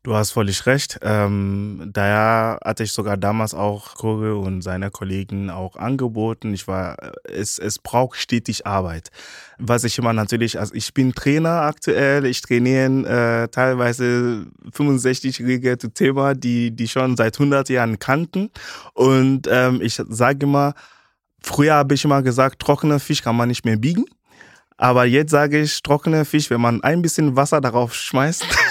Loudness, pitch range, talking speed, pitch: -19 LUFS, 110-140 Hz, 160 wpm, 120 Hz